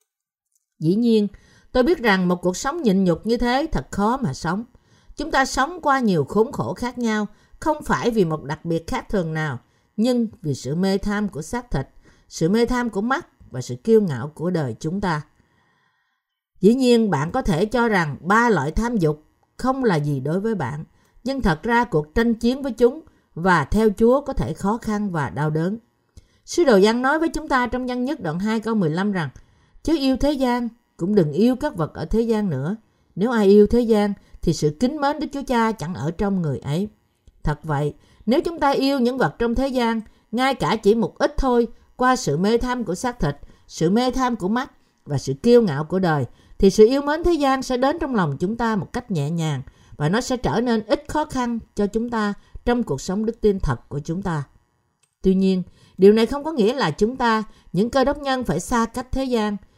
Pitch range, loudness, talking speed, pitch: 170-245 Hz, -21 LUFS, 225 wpm, 215 Hz